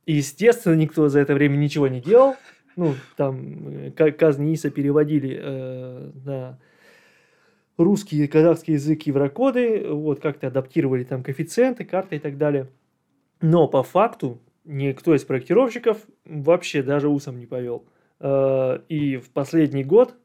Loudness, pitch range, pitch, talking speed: -21 LUFS, 135-165 Hz, 150 Hz, 135 wpm